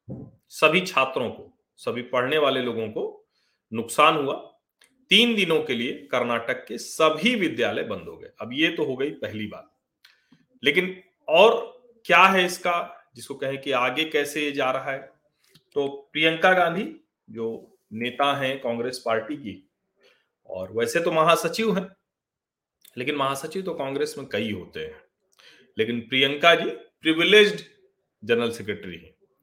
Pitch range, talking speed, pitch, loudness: 130-195 Hz, 145 wpm, 155 Hz, -23 LUFS